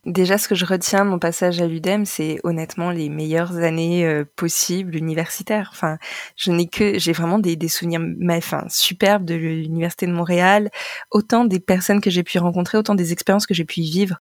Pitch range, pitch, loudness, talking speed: 165-195 Hz, 175 Hz, -19 LUFS, 205 wpm